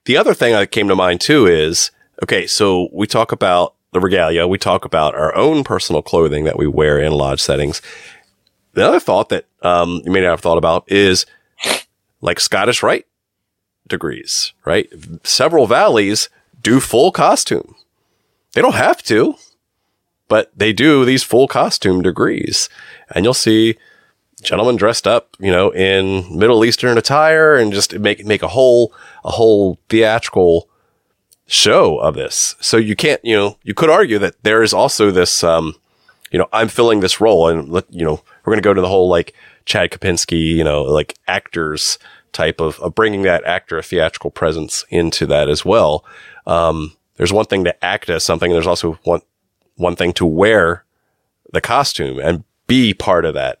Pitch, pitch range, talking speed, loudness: 95 Hz, 85-115 Hz, 180 wpm, -14 LUFS